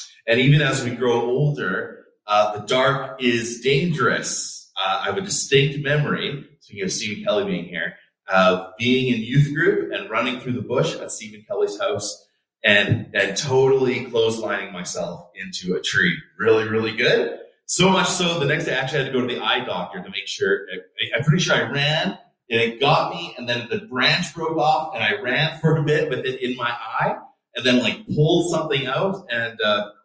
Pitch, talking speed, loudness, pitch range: 135 Hz, 205 wpm, -21 LUFS, 120-160 Hz